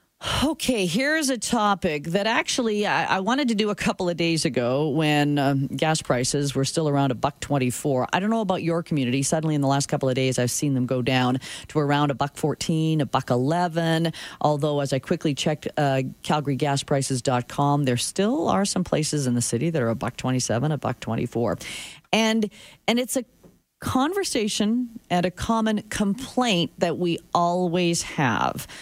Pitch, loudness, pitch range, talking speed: 155 Hz, -24 LUFS, 135-195 Hz, 185 wpm